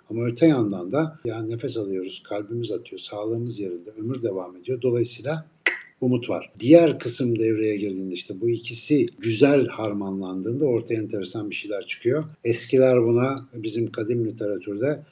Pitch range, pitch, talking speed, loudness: 110-135 Hz, 115 Hz, 145 wpm, -24 LUFS